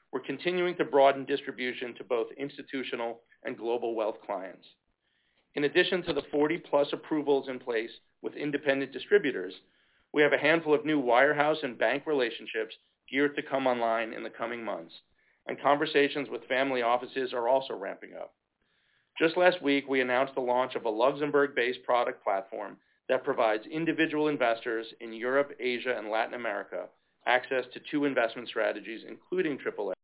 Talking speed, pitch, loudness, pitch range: 160 wpm, 140 Hz, -29 LUFS, 130-155 Hz